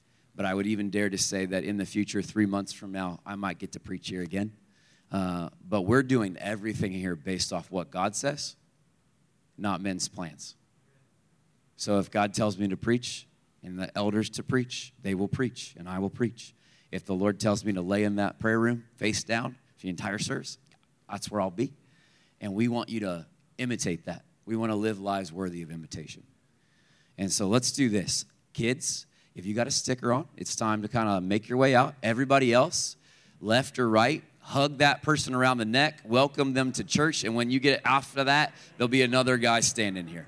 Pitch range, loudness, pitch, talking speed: 100-130 Hz, -28 LUFS, 110 Hz, 210 wpm